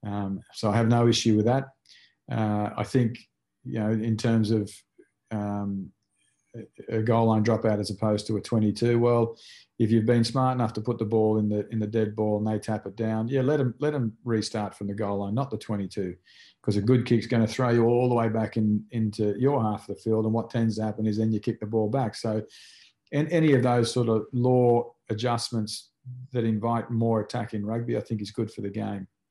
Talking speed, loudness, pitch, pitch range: 230 wpm, -26 LUFS, 110 Hz, 105-120 Hz